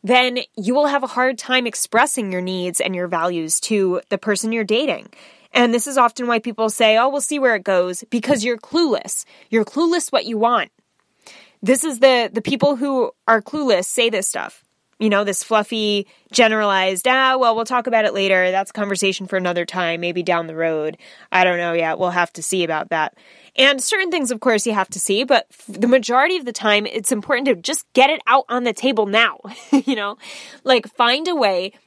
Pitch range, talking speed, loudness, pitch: 195-260 Hz, 215 wpm, -18 LUFS, 230 Hz